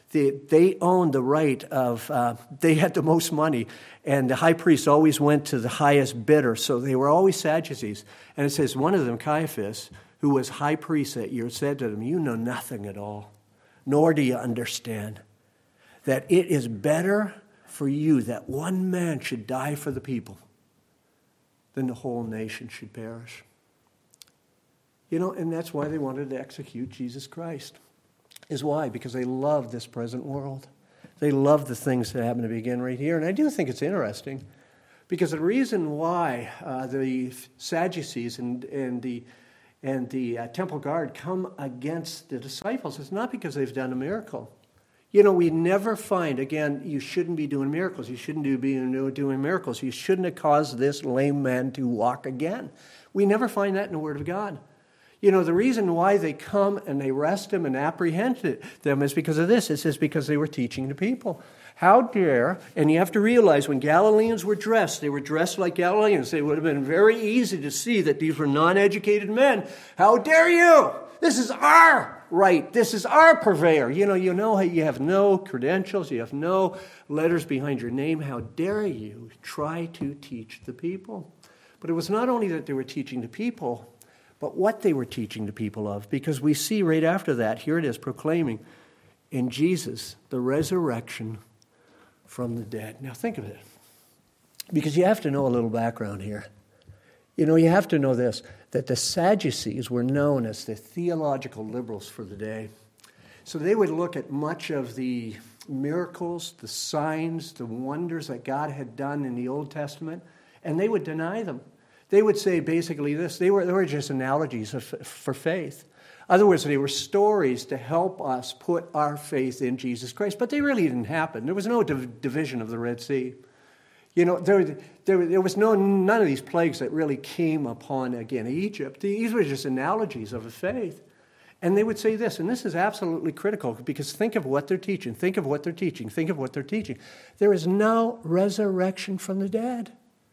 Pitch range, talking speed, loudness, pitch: 130-180 Hz, 190 wpm, -25 LUFS, 150 Hz